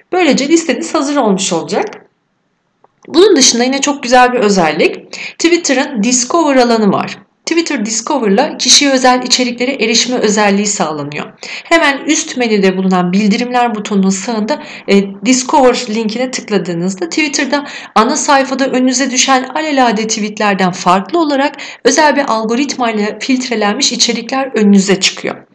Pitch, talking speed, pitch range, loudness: 250 Hz, 120 wpm, 210-280 Hz, -11 LUFS